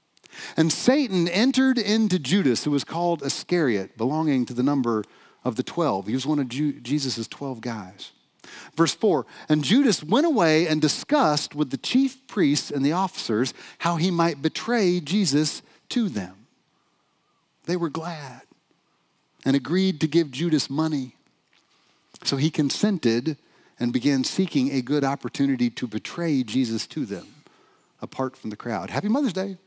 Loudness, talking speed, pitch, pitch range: -24 LUFS, 150 wpm, 155 Hz, 135-180 Hz